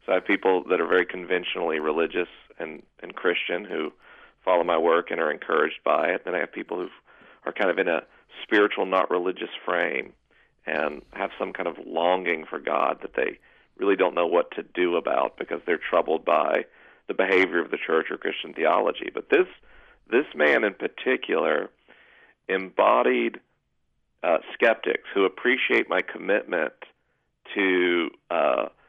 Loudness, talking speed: -25 LUFS, 165 wpm